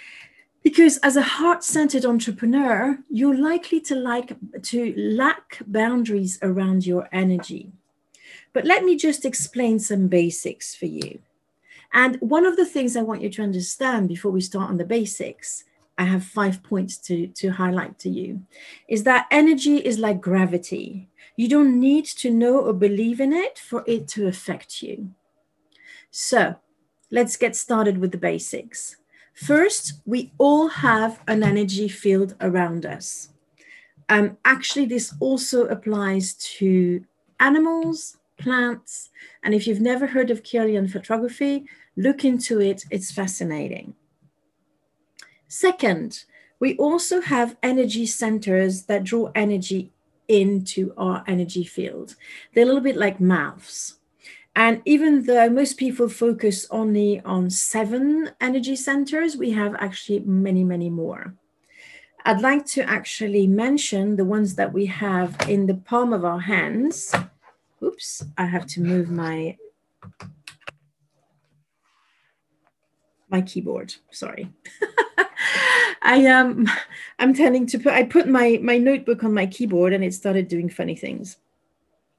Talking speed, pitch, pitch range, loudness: 135 wpm, 225 Hz, 190-265 Hz, -21 LUFS